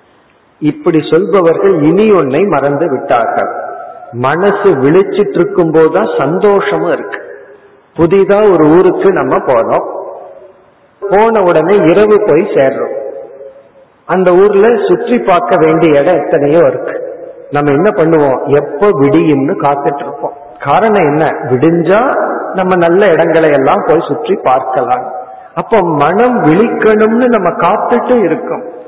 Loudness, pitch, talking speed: -9 LUFS, 195 Hz, 105 wpm